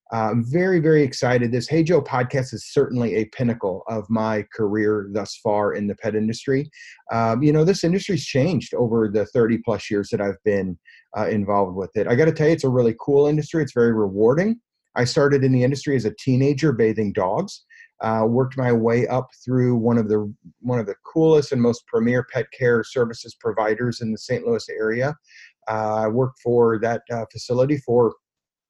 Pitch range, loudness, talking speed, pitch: 110-140 Hz, -21 LUFS, 200 wpm, 120 Hz